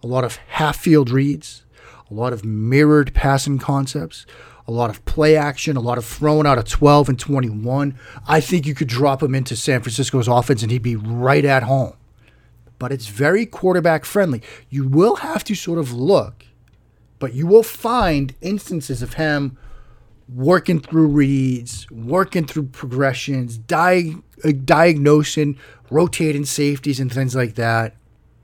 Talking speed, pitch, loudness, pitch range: 160 wpm, 135 Hz, -18 LUFS, 120-150 Hz